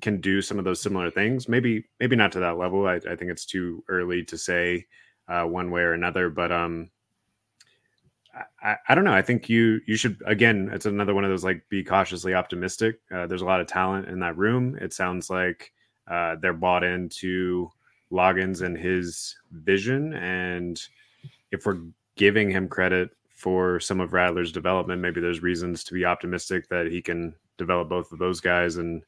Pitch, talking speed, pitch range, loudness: 90 Hz, 190 wpm, 90-100 Hz, -25 LUFS